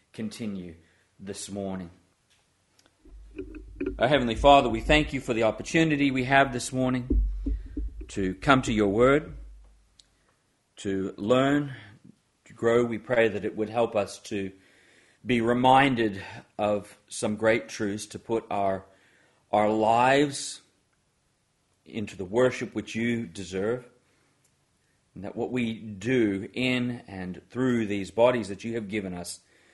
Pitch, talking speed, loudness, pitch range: 110 Hz, 130 wpm, -26 LUFS, 100-125 Hz